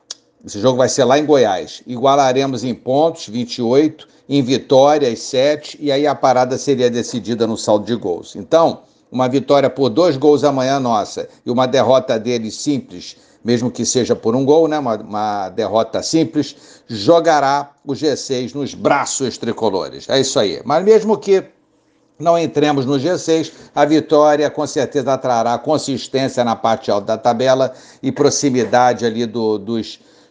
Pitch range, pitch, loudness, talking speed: 120-145 Hz, 135 Hz, -16 LUFS, 160 wpm